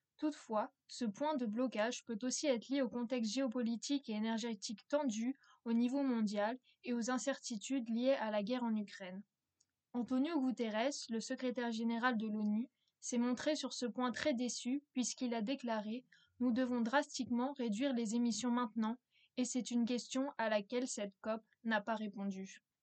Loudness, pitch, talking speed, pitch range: -39 LUFS, 240 Hz, 165 wpm, 225-255 Hz